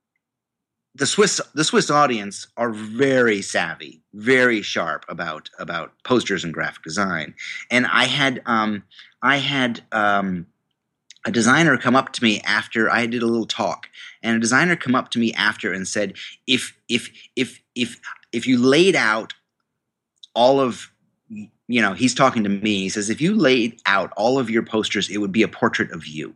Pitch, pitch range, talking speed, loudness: 115 Hz, 105-130 Hz, 180 wpm, -20 LUFS